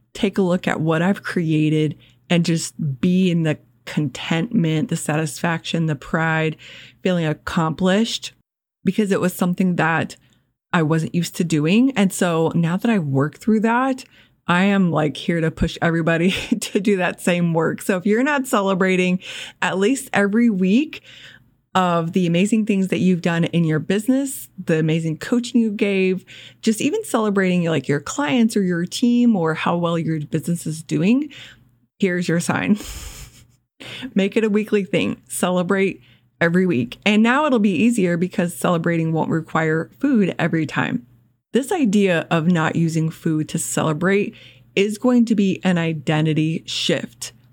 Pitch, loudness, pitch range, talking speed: 175 Hz, -20 LUFS, 160-205 Hz, 160 wpm